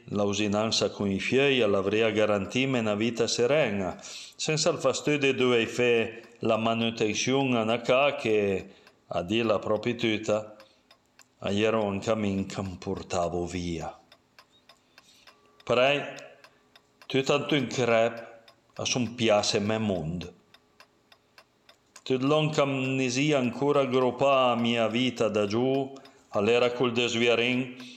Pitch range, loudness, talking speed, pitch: 105-130 Hz, -26 LUFS, 125 wpm, 115 Hz